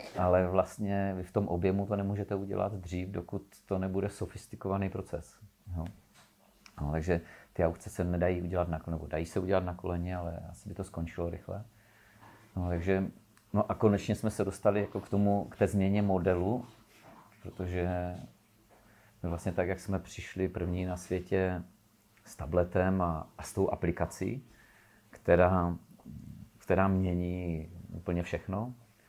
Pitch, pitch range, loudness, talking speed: 95 Hz, 90-105 Hz, -33 LUFS, 150 wpm